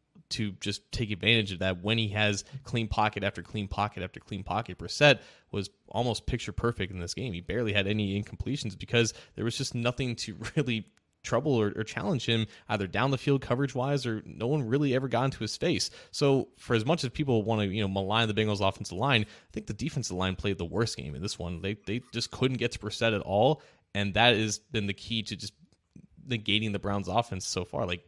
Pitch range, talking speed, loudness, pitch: 100-120 Hz, 230 wpm, -30 LUFS, 110 Hz